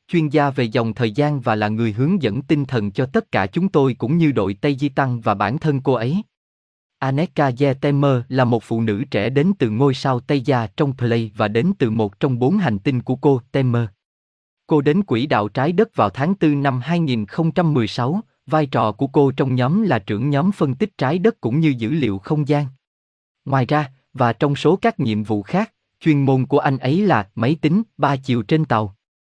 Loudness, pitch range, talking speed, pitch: -19 LUFS, 115-155 Hz, 220 wpm, 140 Hz